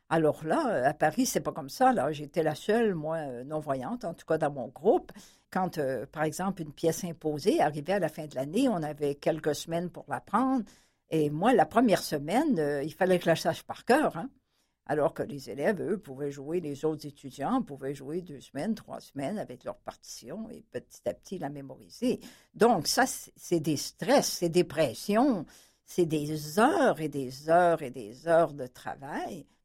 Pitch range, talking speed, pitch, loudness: 145-195 Hz, 200 wpm, 160 Hz, -29 LUFS